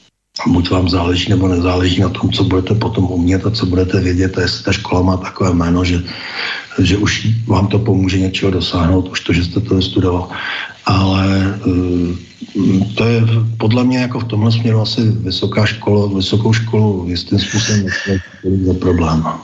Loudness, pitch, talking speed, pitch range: -15 LUFS, 95 Hz, 175 wpm, 90-105 Hz